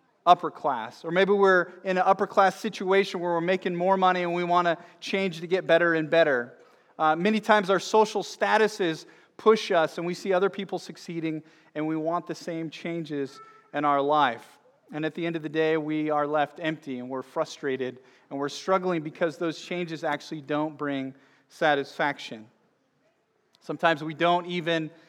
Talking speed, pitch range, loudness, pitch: 180 wpm, 155-185 Hz, -26 LUFS, 165 Hz